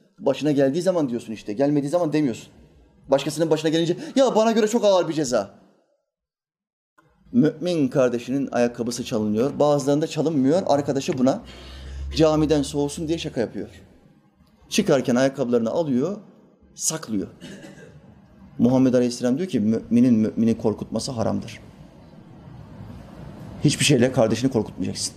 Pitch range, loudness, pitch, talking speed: 125-175 Hz, -22 LUFS, 145 Hz, 110 wpm